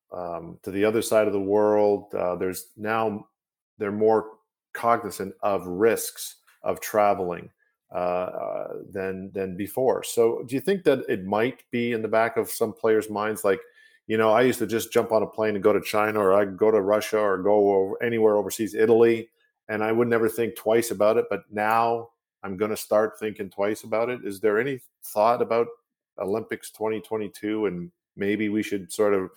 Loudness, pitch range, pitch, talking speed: -24 LUFS, 105-115 Hz, 110 Hz, 195 wpm